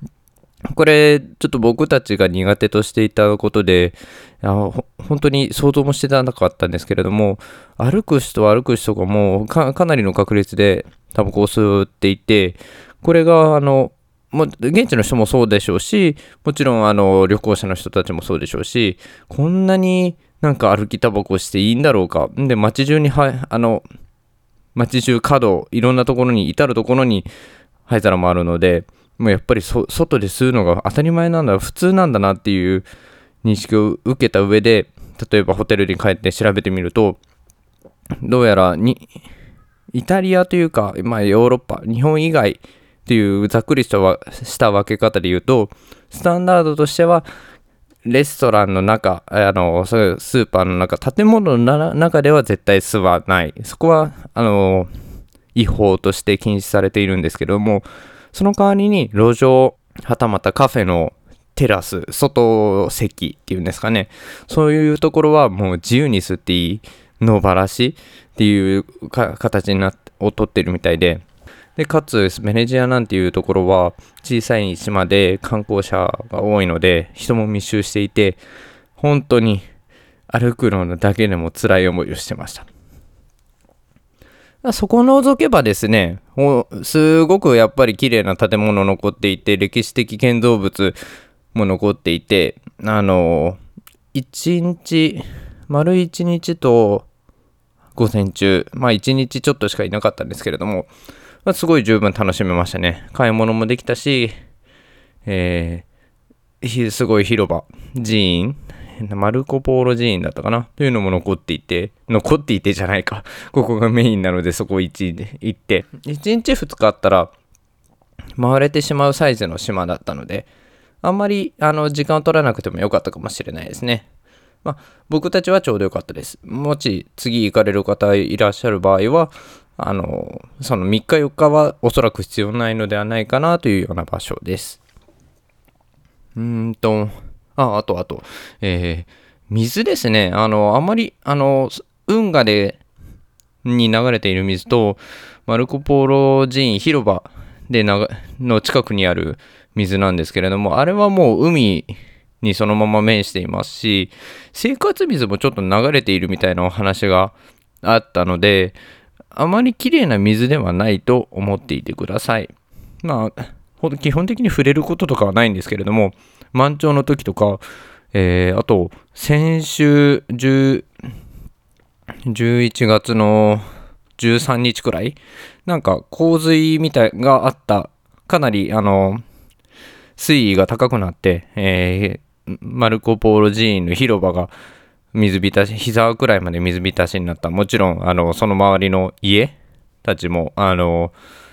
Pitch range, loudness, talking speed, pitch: 95-135 Hz, -16 LUFS, 295 characters per minute, 110 Hz